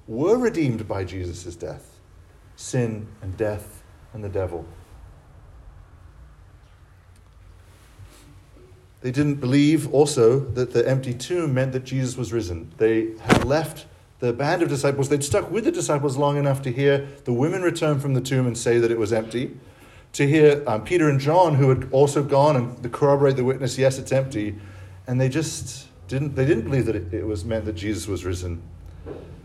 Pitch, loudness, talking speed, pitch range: 120 Hz, -22 LUFS, 175 wpm, 95-140 Hz